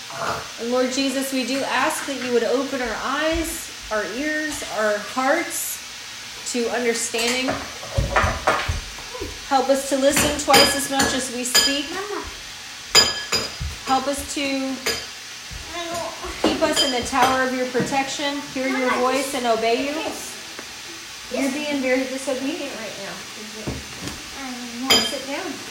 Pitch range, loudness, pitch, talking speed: 250-285 Hz, -22 LUFS, 270 Hz, 125 wpm